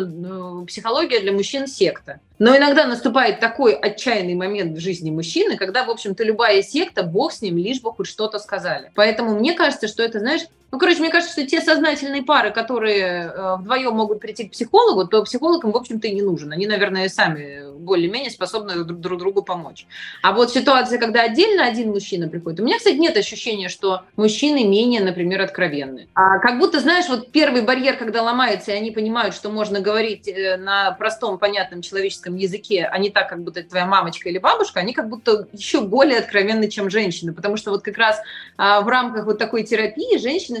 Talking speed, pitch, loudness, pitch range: 190 wpm, 215 Hz, -19 LUFS, 190-245 Hz